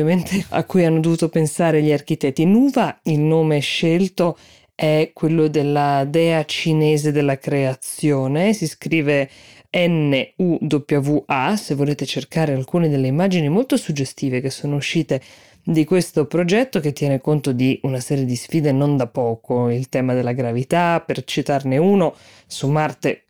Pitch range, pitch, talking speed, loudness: 135-165 Hz, 150 Hz, 150 wpm, -19 LUFS